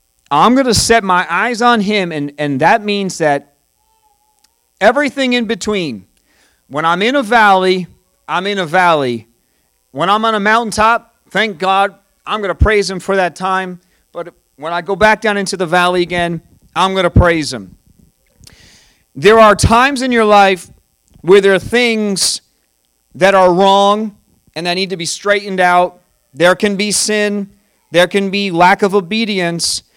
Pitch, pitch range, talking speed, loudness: 195 Hz, 175-215 Hz, 170 wpm, -12 LUFS